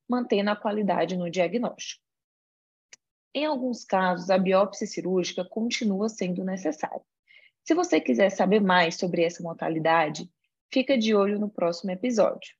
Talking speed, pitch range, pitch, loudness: 135 wpm, 175-220 Hz, 190 Hz, -26 LUFS